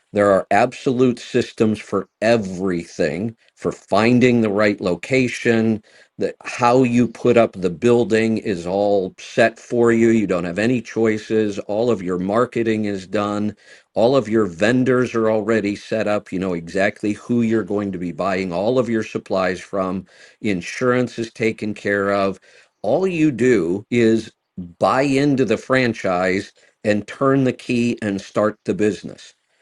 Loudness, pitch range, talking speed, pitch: -19 LUFS, 100-120 Hz, 155 wpm, 110 Hz